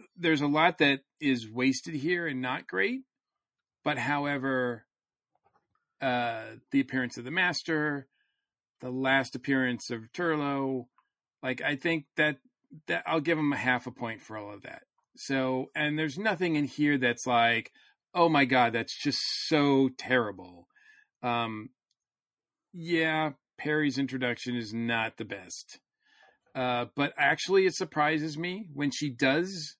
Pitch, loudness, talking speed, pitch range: 140 Hz, -29 LUFS, 145 wpm, 125-160 Hz